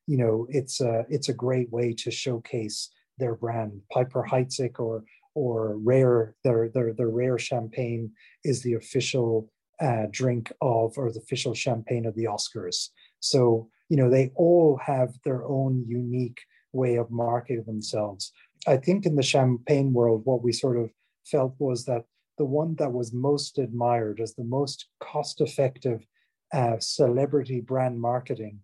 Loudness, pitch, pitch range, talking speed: -26 LUFS, 125 Hz, 115-135 Hz, 160 wpm